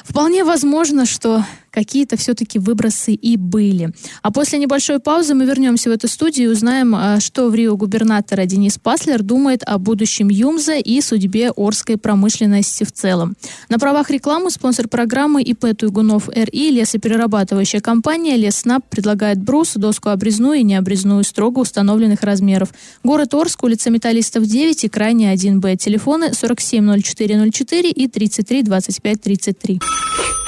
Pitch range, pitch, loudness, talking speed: 210-265 Hz, 225 Hz, -15 LUFS, 130 wpm